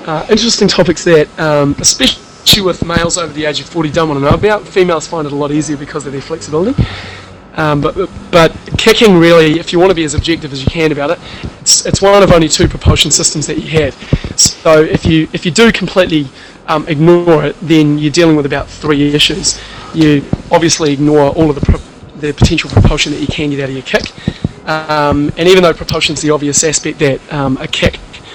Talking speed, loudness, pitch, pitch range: 215 wpm, -10 LUFS, 155 Hz, 145-170 Hz